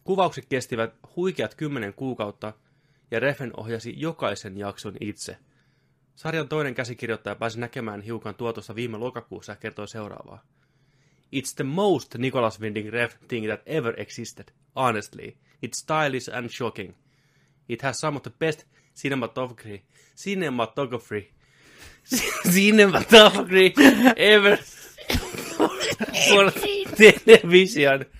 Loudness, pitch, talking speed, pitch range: -20 LUFS, 135 Hz, 105 wpm, 115-155 Hz